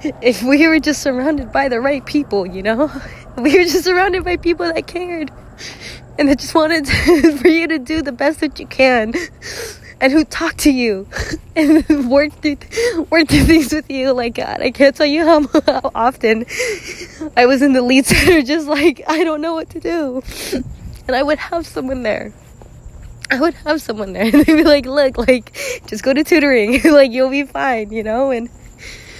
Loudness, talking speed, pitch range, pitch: -15 LUFS, 200 wpm, 260-325 Hz, 295 Hz